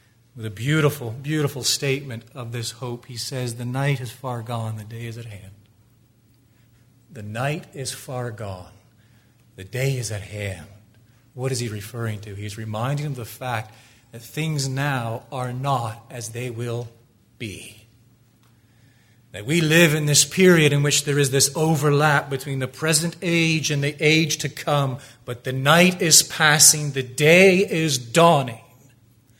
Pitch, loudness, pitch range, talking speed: 125 Hz, -20 LUFS, 115-145 Hz, 165 wpm